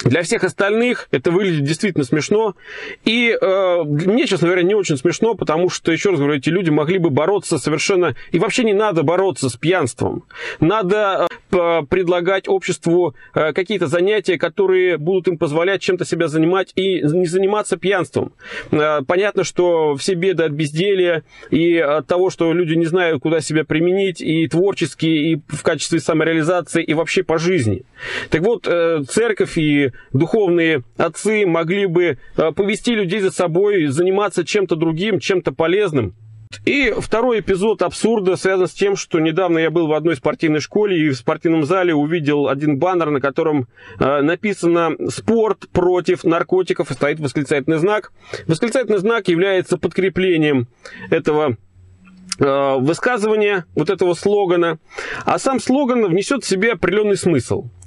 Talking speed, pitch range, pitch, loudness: 145 wpm, 160-195 Hz, 175 Hz, -17 LUFS